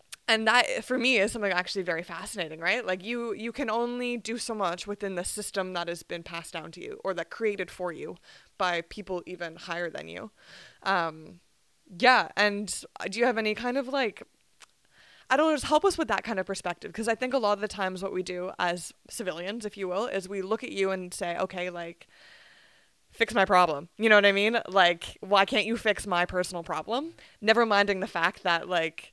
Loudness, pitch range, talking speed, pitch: -28 LUFS, 180-230 Hz, 220 wpm, 195 Hz